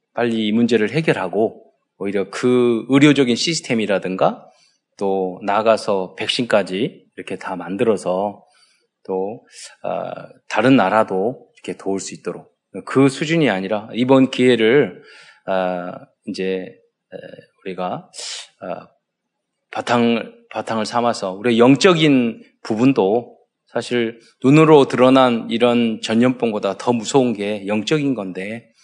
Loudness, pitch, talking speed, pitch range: -18 LUFS, 115 Hz, 240 characters per minute, 100-130 Hz